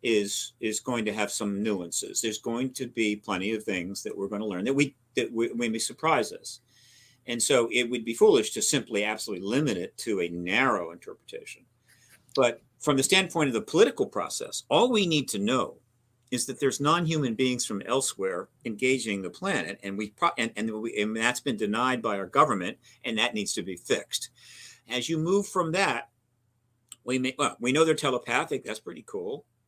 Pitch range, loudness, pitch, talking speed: 110-135 Hz, -27 LUFS, 120 Hz, 200 wpm